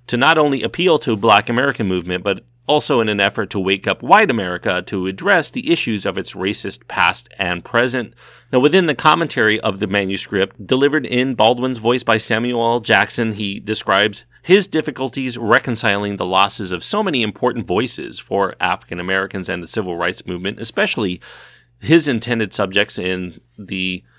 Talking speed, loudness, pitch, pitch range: 170 wpm, -17 LUFS, 110 Hz, 95-125 Hz